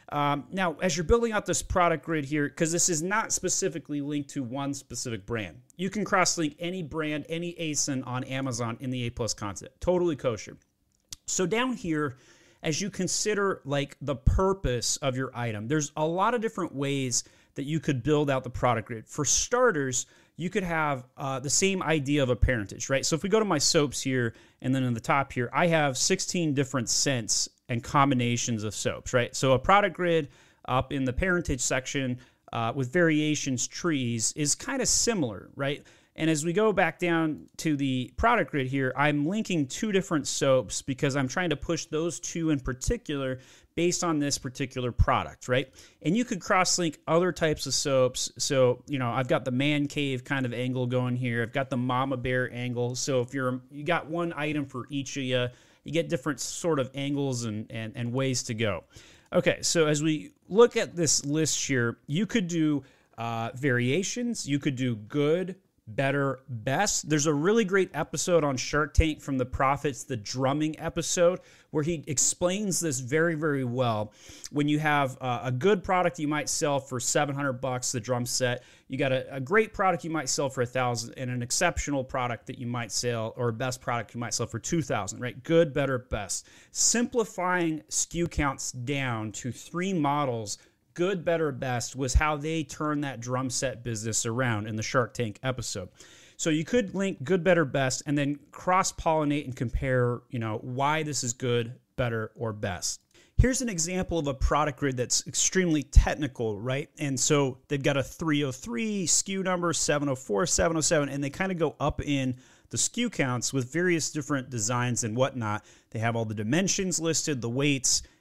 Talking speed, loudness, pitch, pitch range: 190 wpm, -28 LUFS, 140 Hz, 125-165 Hz